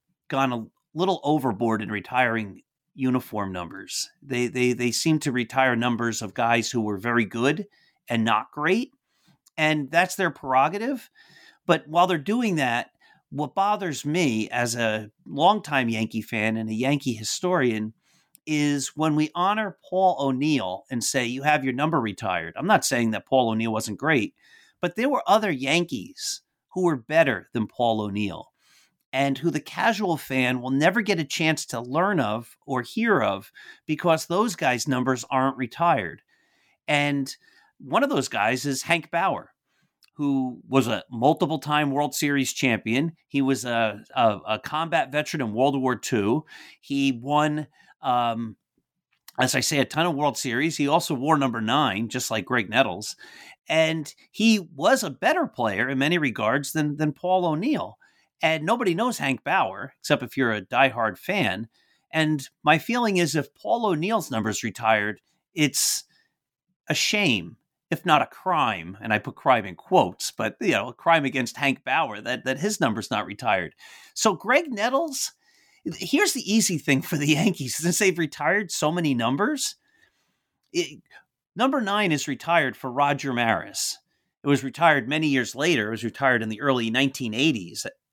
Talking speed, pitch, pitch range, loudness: 165 wpm, 140 Hz, 120-165 Hz, -24 LUFS